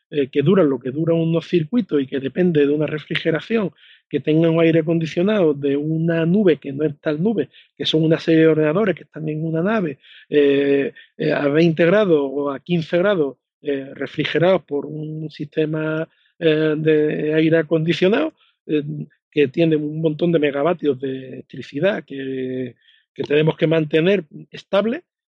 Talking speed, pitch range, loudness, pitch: 165 wpm, 145-165 Hz, -19 LUFS, 155 Hz